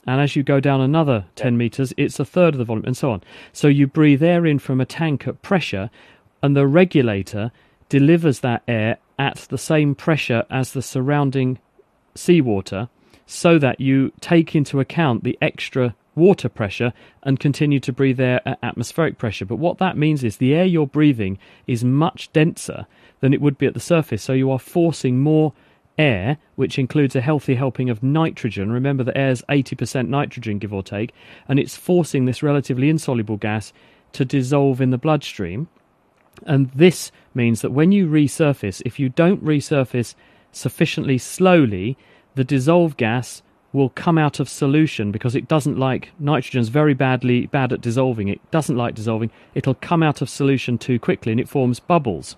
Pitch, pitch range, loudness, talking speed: 135 Hz, 125-150 Hz, -19 LUFS, 180 wpm